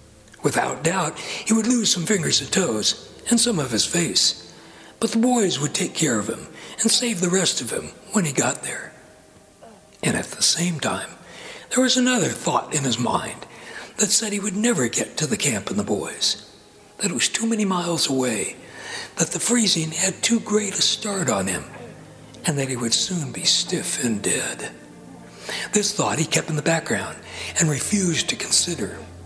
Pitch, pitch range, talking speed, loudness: 180 Hz, 150-220 Hz, 190 wpm, -21 LUFS